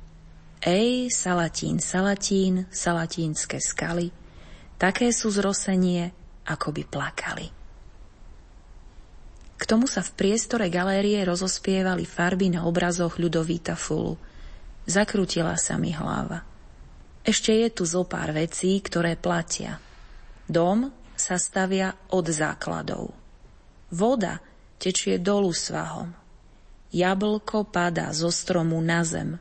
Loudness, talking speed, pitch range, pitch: -25 LUFS, 100 wpm, 170-200 Hz, 180 Hz